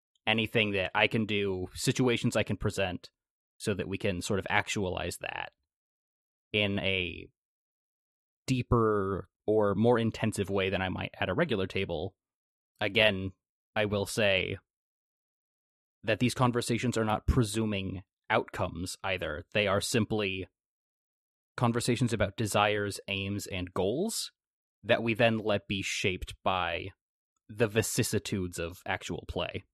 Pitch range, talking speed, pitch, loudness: 95-110 Hz, 130 wpm, 105 Hz, -30 LUFS